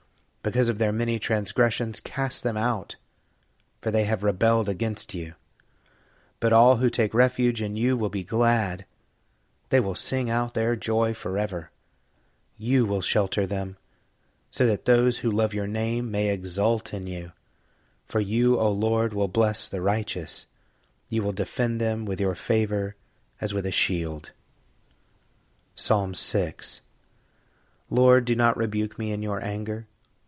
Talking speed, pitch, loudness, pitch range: 150 wpm, 110 Hz, -25 LUFS, 100-115 Hz